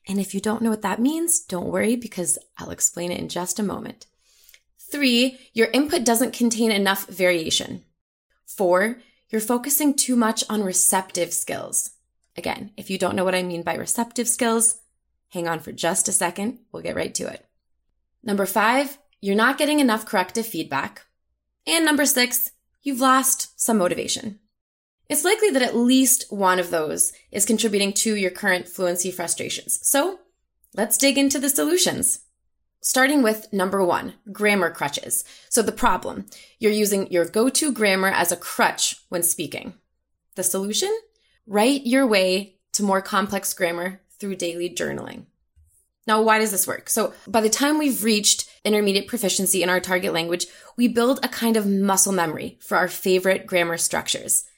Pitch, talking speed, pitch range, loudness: 210 Hz, 165 wpm, 185-245 Hz, -21 LUFS